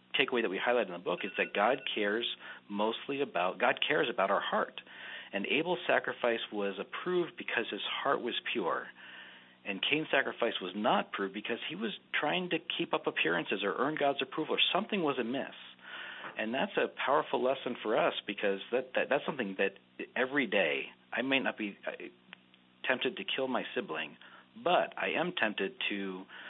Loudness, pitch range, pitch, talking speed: -33 LUFS, 100-140 Hz, 115 Hz, 180 wpm